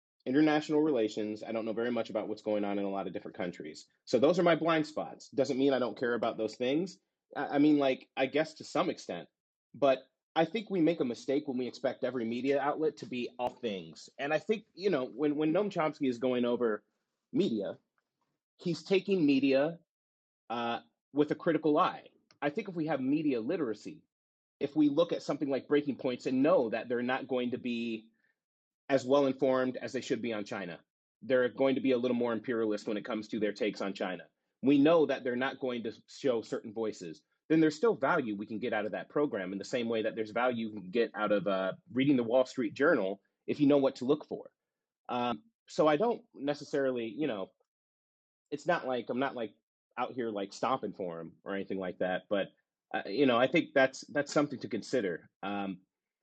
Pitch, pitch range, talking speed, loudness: 130 Hz, 115-150 Hz, 220 wpm, -32 LUFS